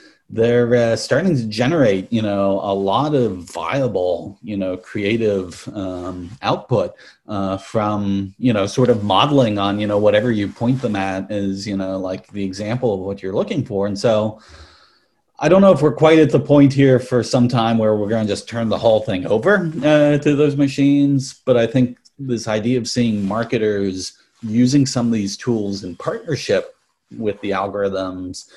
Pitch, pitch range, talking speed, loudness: 110 Hz, 100-125 Hz, 185 wpm, -18 LUFS